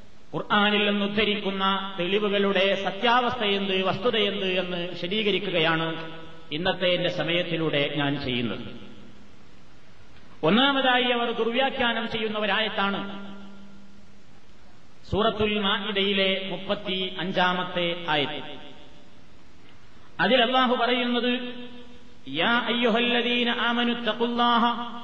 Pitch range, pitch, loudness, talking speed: 175-235 Hz, 200 Hz, -24 LUFS, 55 wpm